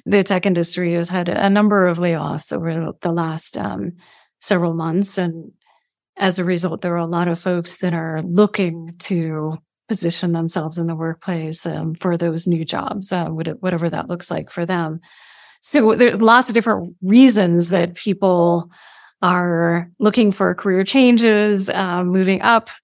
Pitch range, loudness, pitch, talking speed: 170-195 Hz, -18 LUFS, 180 Hz, 165 wpm